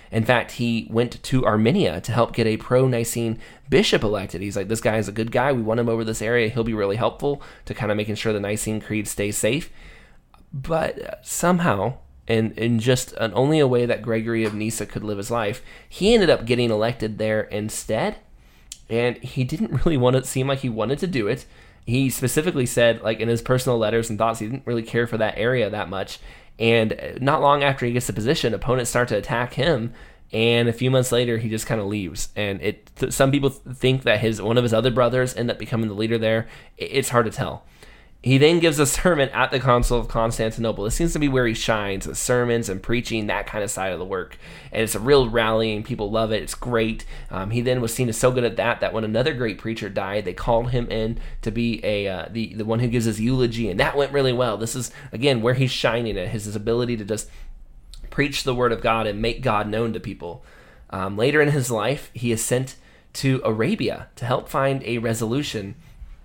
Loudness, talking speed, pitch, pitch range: -22 LUFS, 235 wpm, 115 Hz, 110-125 Hz